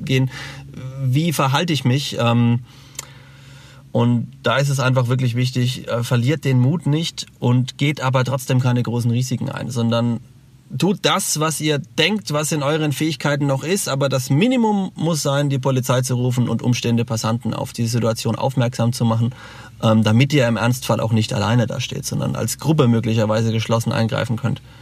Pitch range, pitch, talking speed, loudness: 120-140 Hz, 130 Hz, 170 wpm, -19 LUFS